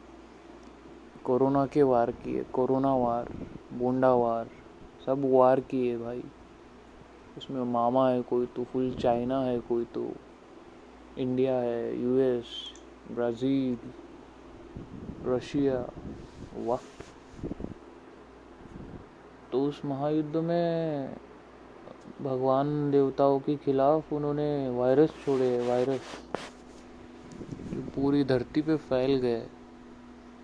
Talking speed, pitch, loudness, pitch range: 90 wpm, 130 Hz, -28 LUFS, 120-140 Hz